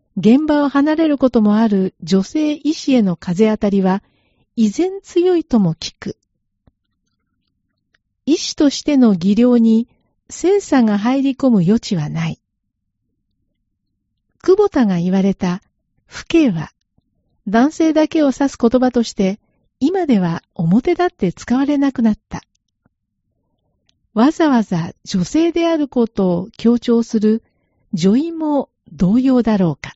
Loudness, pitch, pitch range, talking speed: -16 LUFS, 230 Hz, 190-285 Hz, 230 characters per minute